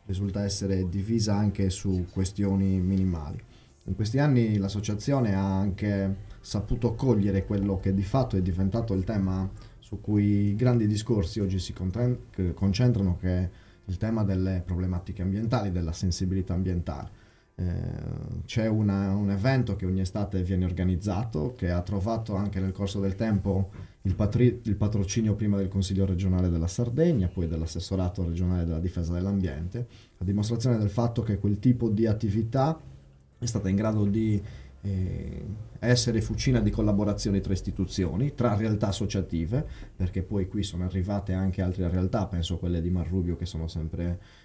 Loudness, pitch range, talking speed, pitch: -28 LUFS, 95-110 Hz, 155 wpm, 100 Hz